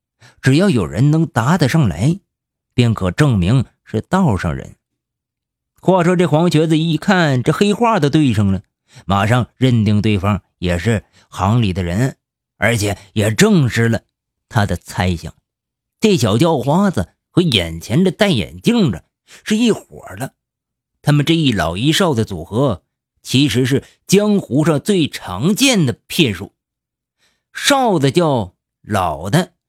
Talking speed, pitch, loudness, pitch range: 200 characters per minute, 130 Hz, -16 LUFS, 105-165 Hz